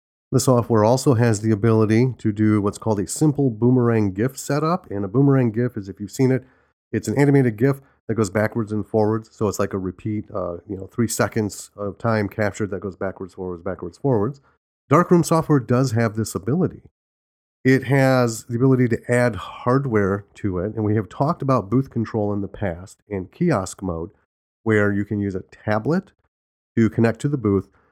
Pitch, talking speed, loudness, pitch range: 110 Hz, 195 wpm, -21 LUFS, 100-130 Hz